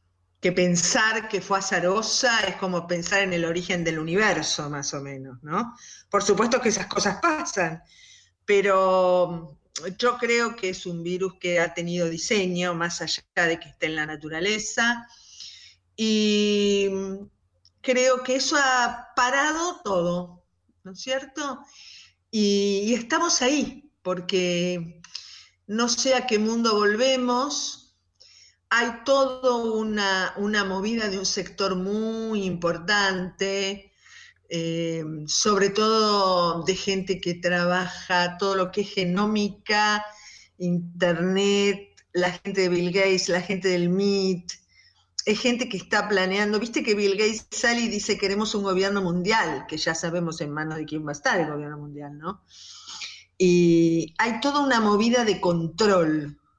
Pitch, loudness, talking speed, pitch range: 195 Hz, -24 LUFS, 140 wpm, 175-220 Hz